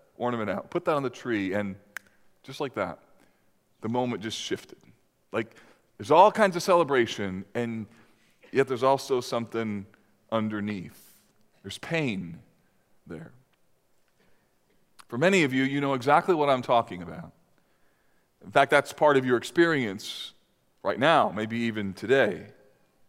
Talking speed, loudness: 140 wpm, -26 LUFS